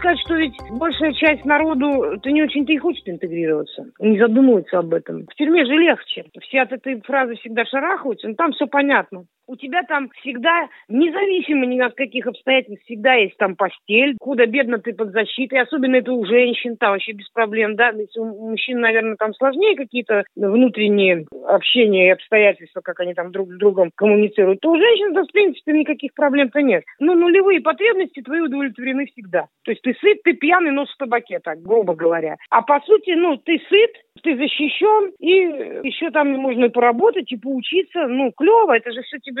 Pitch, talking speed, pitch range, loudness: 260 Hz, 185 wpm, 220-310 Hz, -17 LUFS